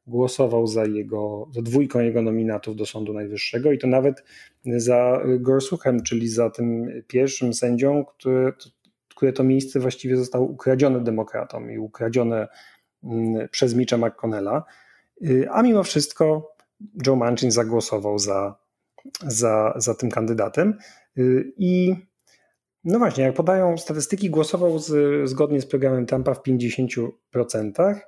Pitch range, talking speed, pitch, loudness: 115-140 Hz, 125 wpm, 125 Hz, -22 LUFS